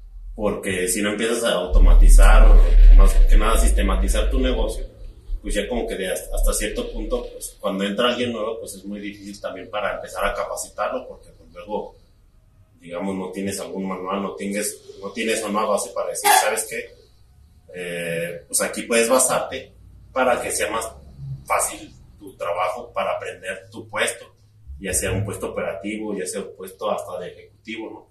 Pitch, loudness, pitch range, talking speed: 100 Hz, -22 LUFS, 95-125 Hz, 175 wpm